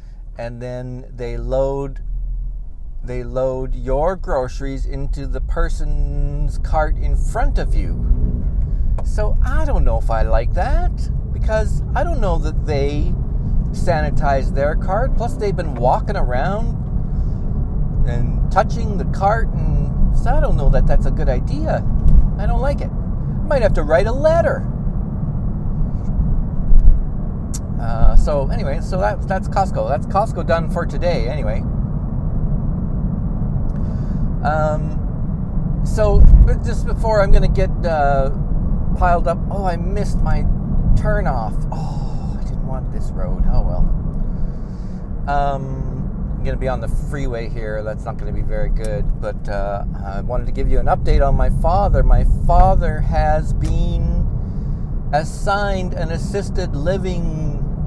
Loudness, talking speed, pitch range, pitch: -20 LUFS, 140 wpm, 100-140 Hz, 130 Hz